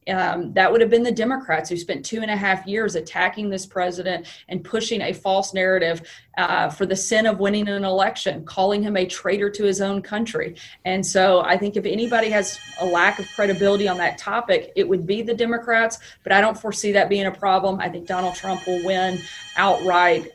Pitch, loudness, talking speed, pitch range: 195 Hz, -21 LUFS, 210 wpm, 185-210 Hz